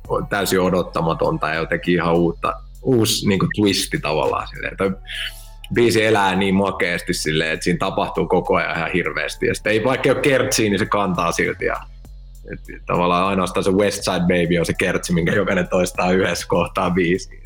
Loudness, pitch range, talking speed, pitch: -19 LUFS, 90-110 Hz, 170 wpm, 95 Hz